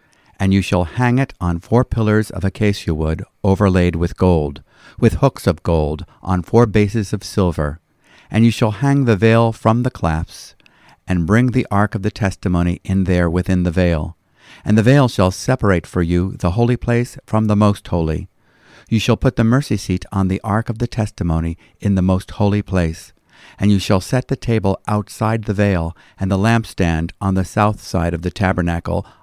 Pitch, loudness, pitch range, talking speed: 100 Hz, -17 LUFS, 90-110 Hz, 195 wpm